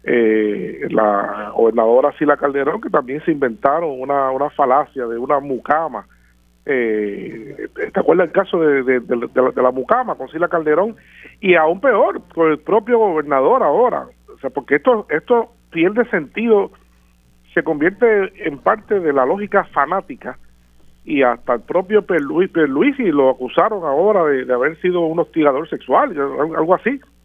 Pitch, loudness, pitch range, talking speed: 150 Hz, -17 LUFS, 125-195 Hz, 165 wpm